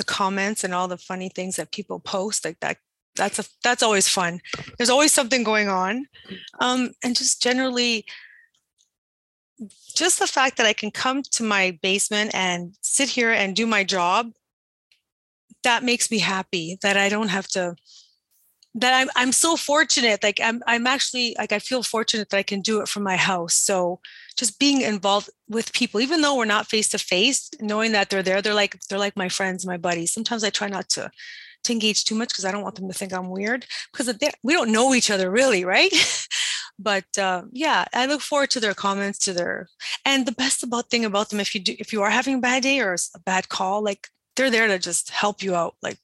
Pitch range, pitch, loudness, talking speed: 195-245 Hz, 215 Hz, -21 LUFS, 210 wpm